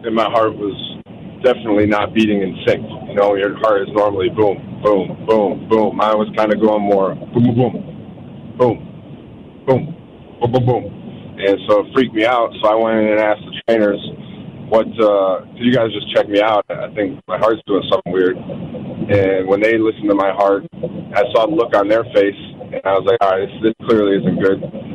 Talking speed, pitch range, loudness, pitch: 210 wpm, 100-115 Hz, -16 LUFS, 105 Hz